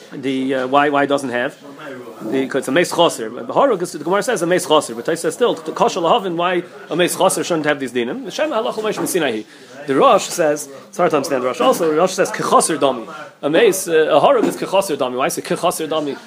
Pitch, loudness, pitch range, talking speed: 155 Hz, -17 LUFS, 135-180 Hz, 205 wpm